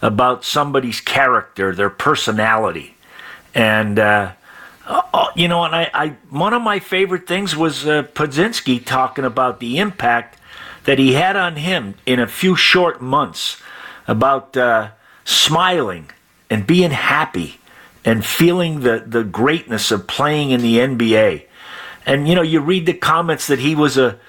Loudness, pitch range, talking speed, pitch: -16 LUFS, 120-170 Hz, 155 wpm, 135 Hz